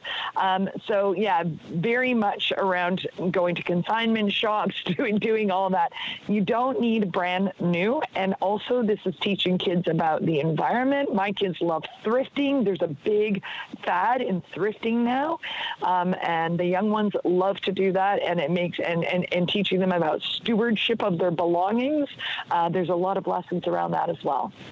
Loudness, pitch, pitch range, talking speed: -25 LUFS, 195 Hz, 180-220 Hz, 170 wpm